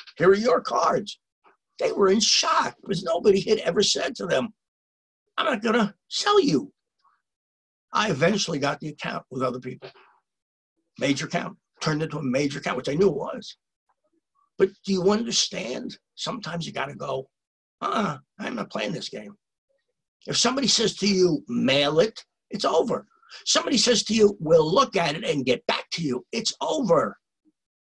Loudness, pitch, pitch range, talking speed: -24 LUFS, 200 Hz, 170-245 Hz, 170 wpm